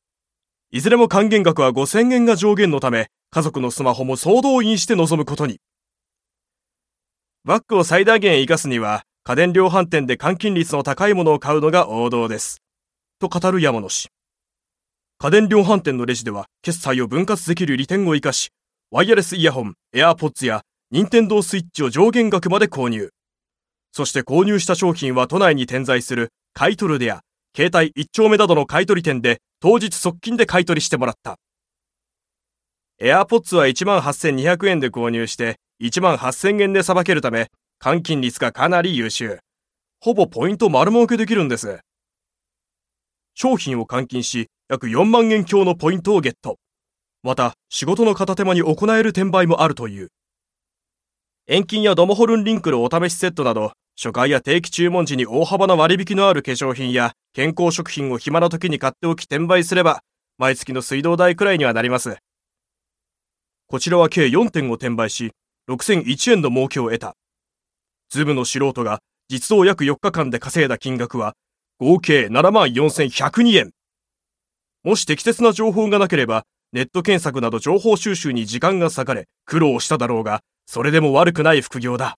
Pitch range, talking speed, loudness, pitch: 125-190 Hz, 310 characters per minute, -17 LUFS, 155 Hz